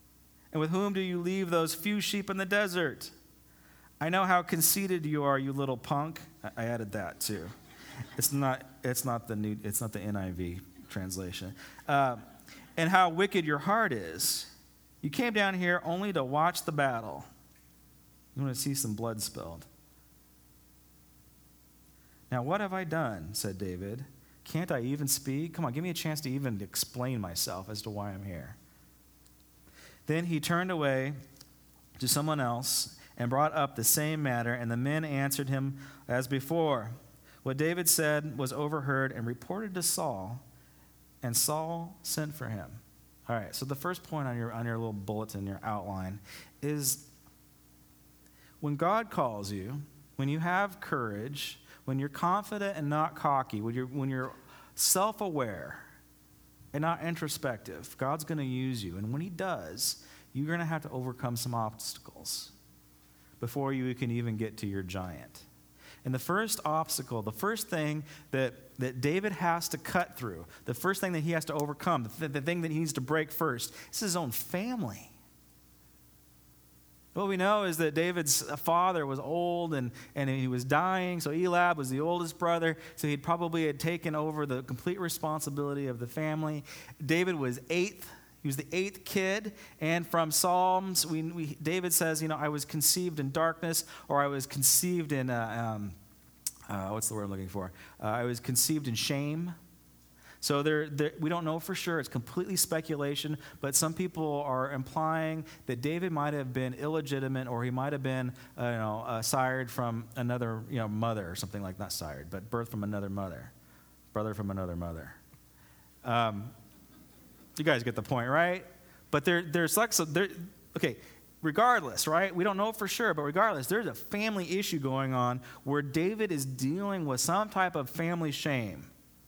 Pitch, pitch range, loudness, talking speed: 140 Hz, 110-165 Hz, -32 LUFS, 175 wpm